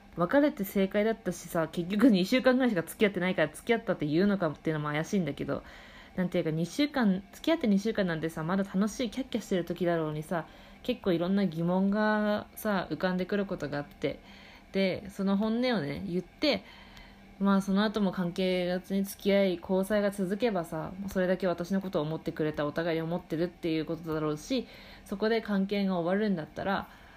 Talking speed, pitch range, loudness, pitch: 420 characters per minute, 170-210 Hz, -30 LUFS, 190 Hz